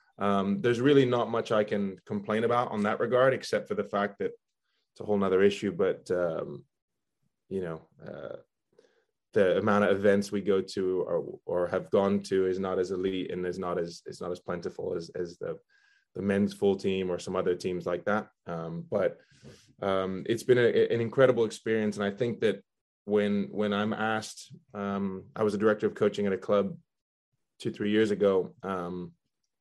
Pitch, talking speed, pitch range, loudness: 105 Hz, 195 wpm, 100-140 Hz, -29 LUFS